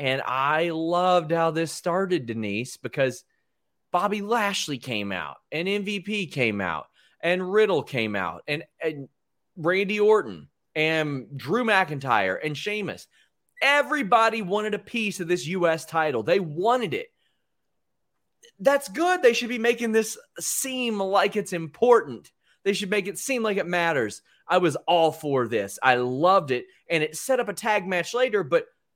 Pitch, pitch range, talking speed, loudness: 180 Hz, 155-215 Hz, 160 wpm, -24 LUFS